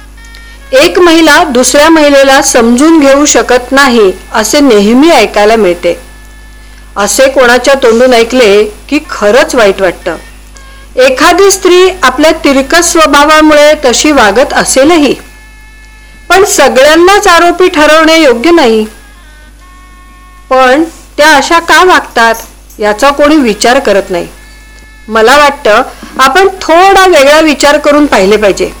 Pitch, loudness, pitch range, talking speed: 285 Hz, -4 LUFS, 235-330 Hz, 110 wpm